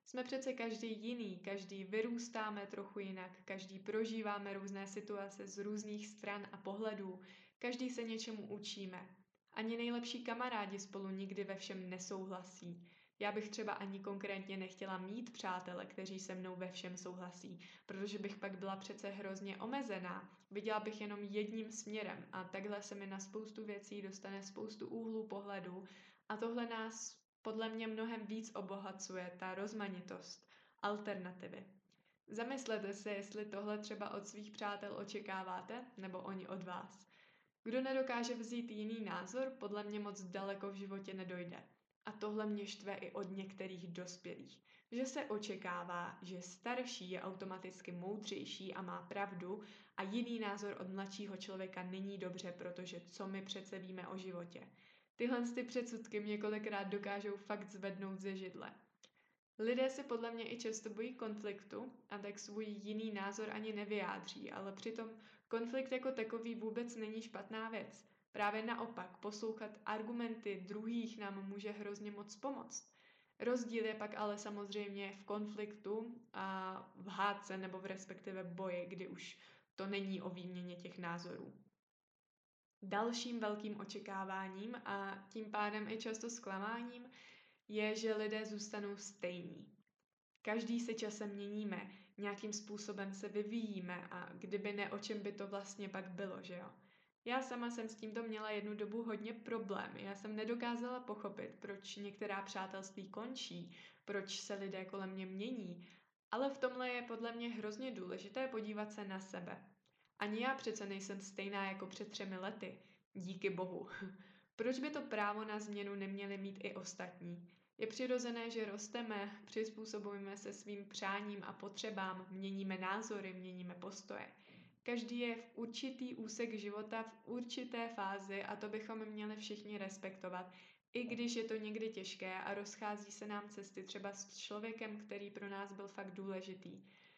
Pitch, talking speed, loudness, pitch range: 205 Hz, 150 wpm, -46 LUFS, 195-220 Hz